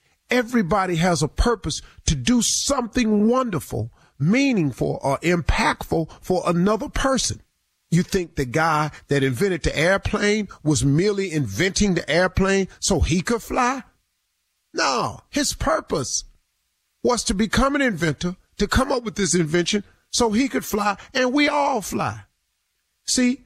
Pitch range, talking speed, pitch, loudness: 170-245 Hz, 140 wpm, 195 Hz, -21 LUFS